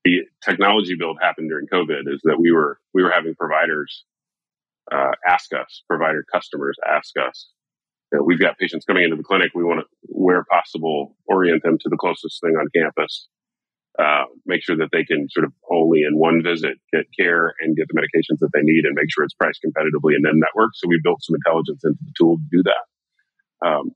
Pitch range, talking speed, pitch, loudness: 80-90 Hz, 215 wpm, 85 Hz, -19 LUFS